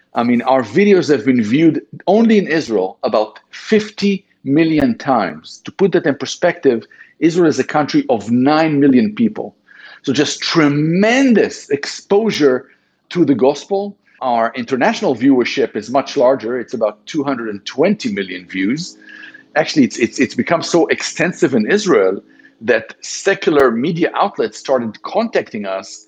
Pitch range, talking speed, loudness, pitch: 135-215 Hz, 140 wpm, -15 LUFS, 175 Hz